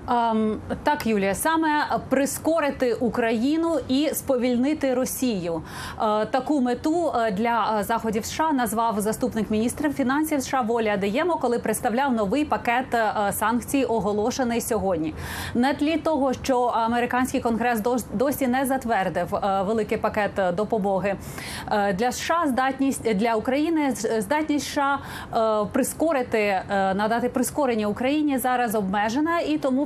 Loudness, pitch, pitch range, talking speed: -24 LUFS, 245 Hz, 220-275 Hz, 110 wpm